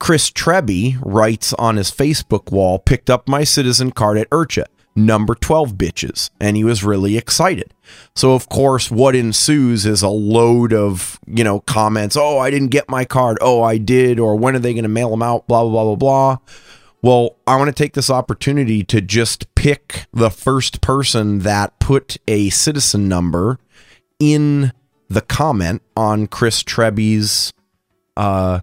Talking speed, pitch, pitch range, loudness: 170 wpm, 115 Hz, 105-130 Hz, -15 LUFS